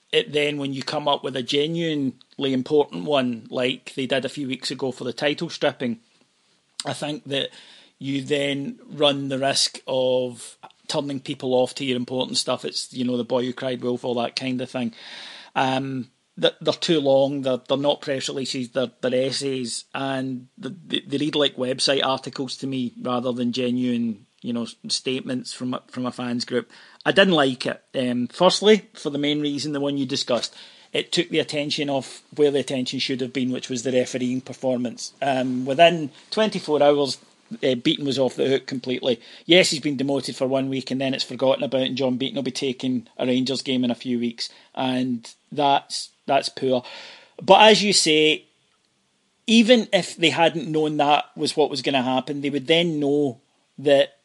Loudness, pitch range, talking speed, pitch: -23 LUFS, 130-150 Hz, 190 wpm, 135 Hz